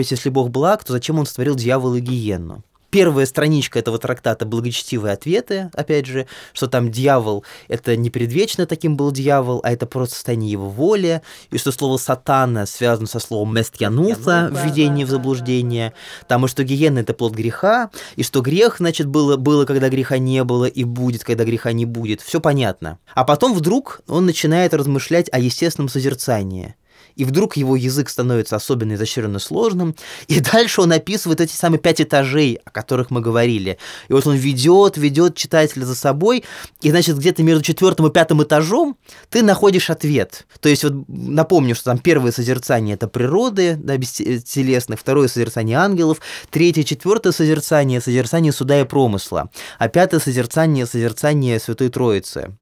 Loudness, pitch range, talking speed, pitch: -17 LUFS, 120-160 Hz, 165 wpm, 135 Hz